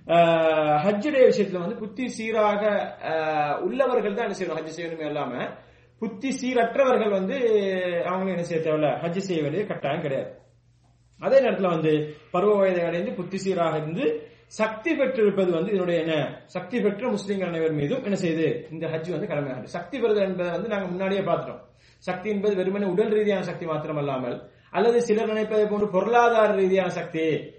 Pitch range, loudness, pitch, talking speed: 160-210 Hz, -24 LUFS, 180 Hz, 140 wpm